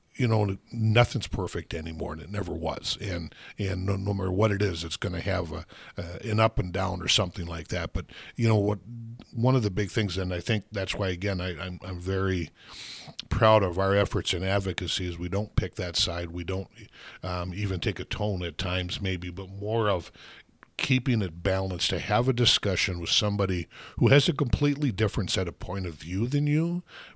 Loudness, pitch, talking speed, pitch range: -28 LUFS, 100 Hz, 210 wpm, 90-110 Hz